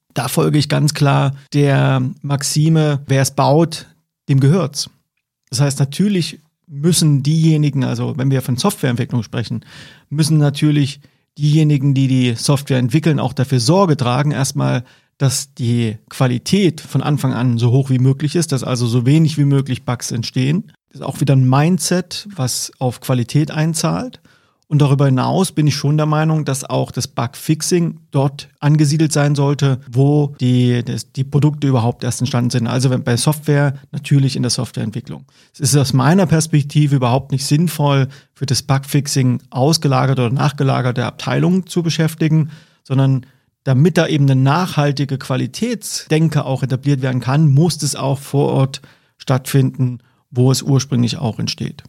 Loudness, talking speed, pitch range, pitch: -16 LUFS, 155 wpm, 130-150 Hz, 140 Hz